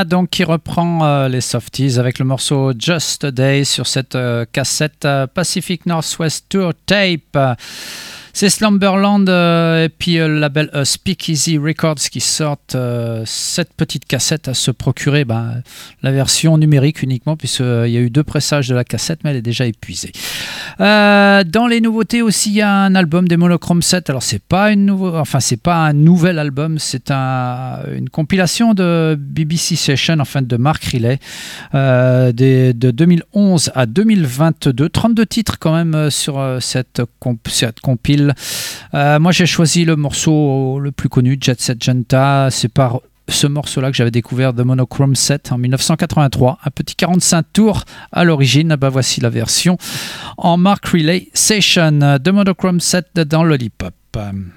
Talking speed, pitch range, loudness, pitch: 170 wpm, 130-170 Hz, -14 LUFS, 150 Hz